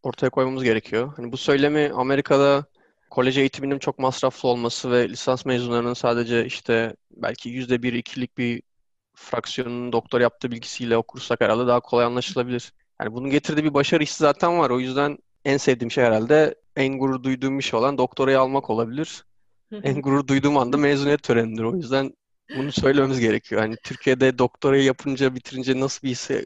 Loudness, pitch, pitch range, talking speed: -22 LUFS, 130 Hz, 120-140 Hz, 165 wpm